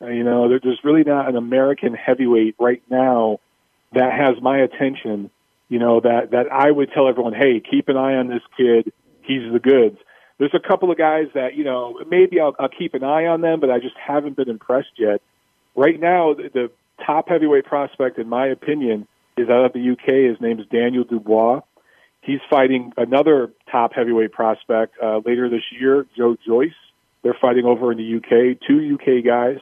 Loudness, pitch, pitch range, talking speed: -18 LUFS, 125 Hz, 120-140 Hz, 195 wpm